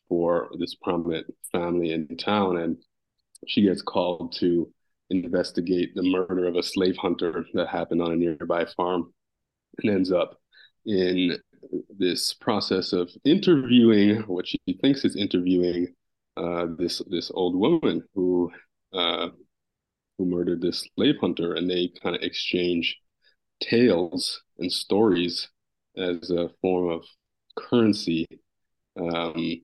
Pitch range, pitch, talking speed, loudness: 85-90 Hz, 90 Hz, 130 wpm, -25 LUFS